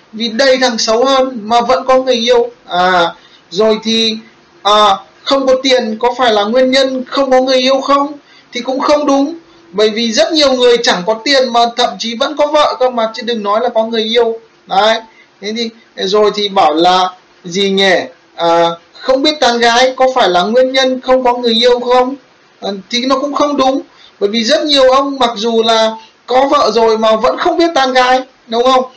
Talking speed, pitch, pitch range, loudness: 215 wpm, 245 Hz, 220-265 Hz, -11 LUFS